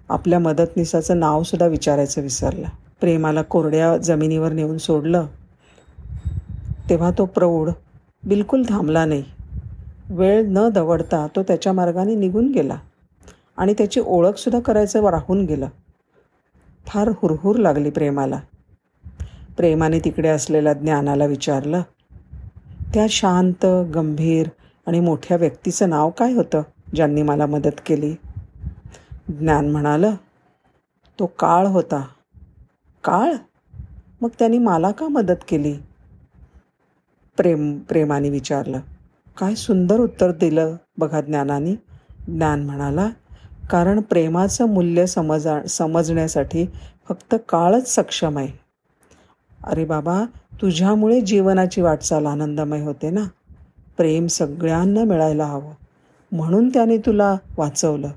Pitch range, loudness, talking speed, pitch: 150-190 Hz, -19 LUFS, 105 wpm, 165 Hz